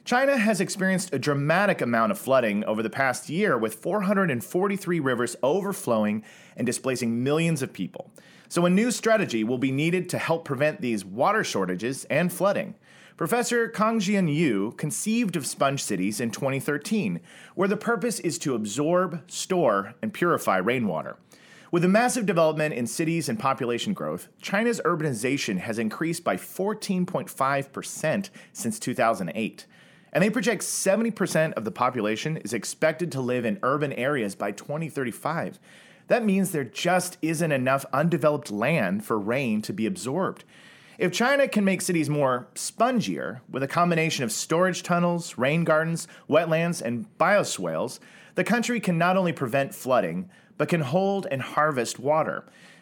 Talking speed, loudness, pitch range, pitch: 150 wpm, -25 LUFS, 135-195 Hz, 165 Hz